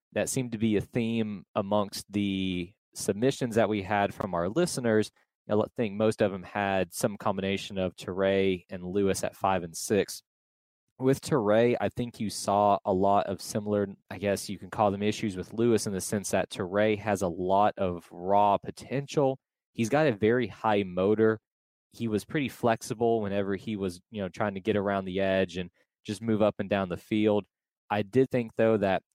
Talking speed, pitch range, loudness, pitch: 195 wpm, 95-115 Hz, -28 LUFS, 105 Hz